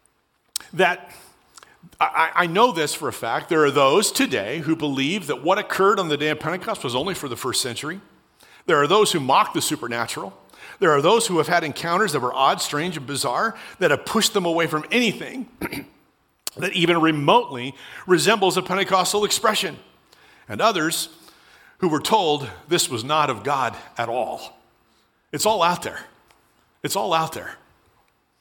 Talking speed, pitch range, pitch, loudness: 175 wpm, 150-195 Hz, 170 Hz, -21 LUFS